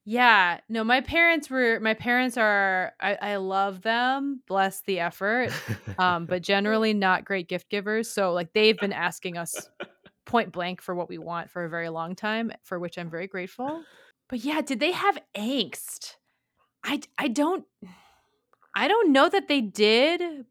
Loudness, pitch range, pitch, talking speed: -25 LUFS, 185-260 Hz, 215 Hz, 175 wpm